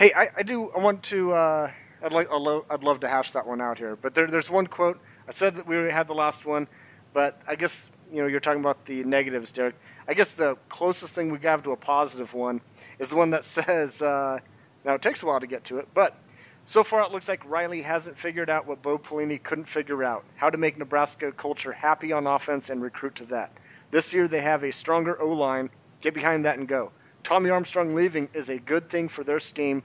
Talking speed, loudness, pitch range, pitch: 245 wpm, -26 LUFS, 135-165 Hz, 150 Hz